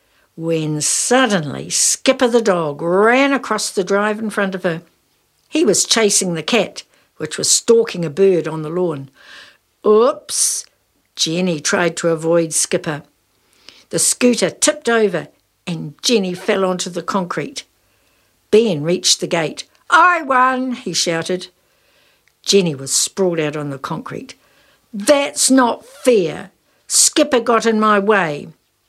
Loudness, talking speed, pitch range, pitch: -16 LUFS, 135 wpm, 165-230 Hz, 190 Hz